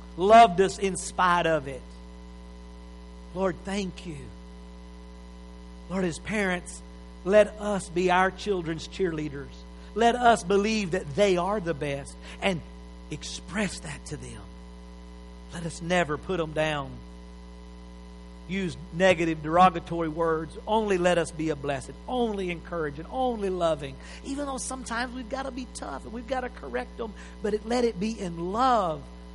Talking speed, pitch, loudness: 145 wpm, 170 Hz, -27 LUFS